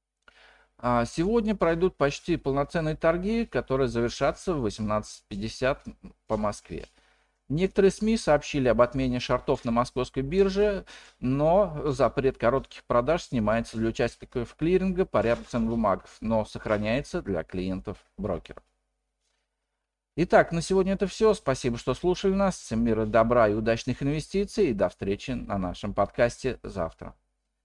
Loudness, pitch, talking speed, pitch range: -27 LUFS, 130 Hz, 125 wpm, 115-175 Hz